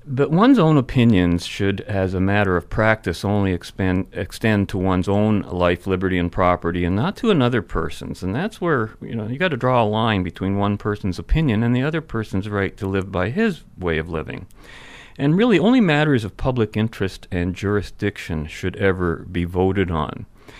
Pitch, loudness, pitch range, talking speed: 100 Hz, -20 LUFS, 90-120 Hz, 190 wpm